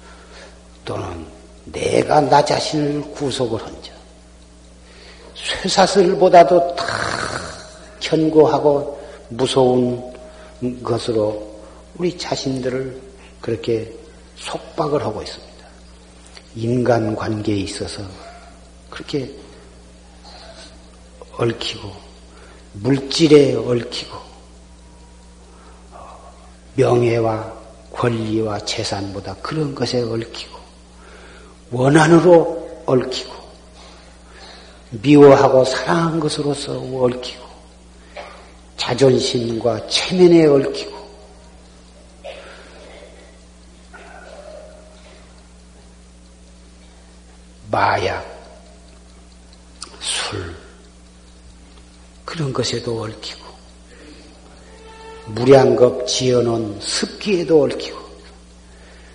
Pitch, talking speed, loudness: 100 Hz, 140 characters per minute, -17 LUFS